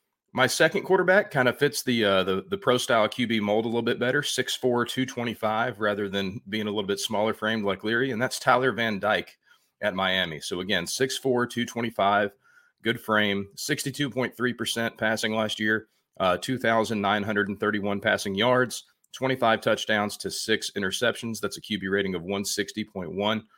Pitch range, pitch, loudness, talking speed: 105-125 Hz, 110 Hz, -26 LUFS, 160 wpm